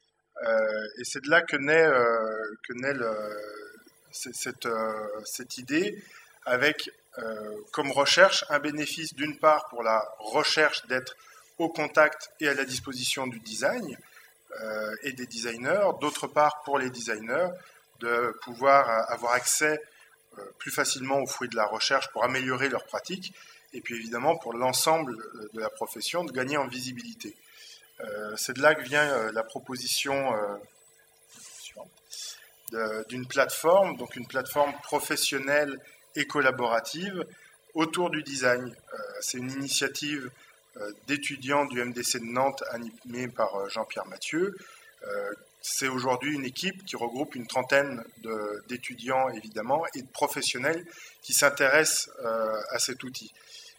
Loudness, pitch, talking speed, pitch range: -28 LUFS, 130 Hz, 145 wpm, 120-150 Hz